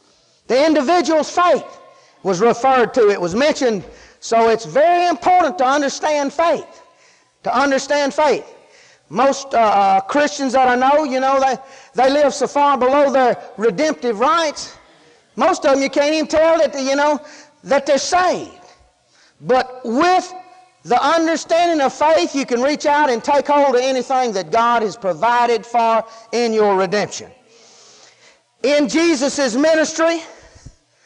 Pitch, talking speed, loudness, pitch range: 275 Hz, 145 wpm, -16 LUFS, 245-310 Hz